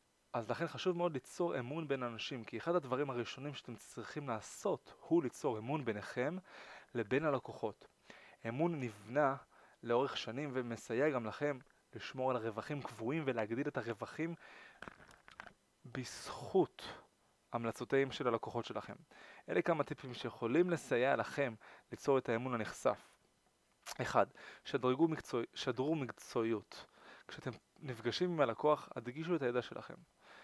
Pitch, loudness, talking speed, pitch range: 130 Hz, -39 LUFS, 125 wpm, 115-150 Hz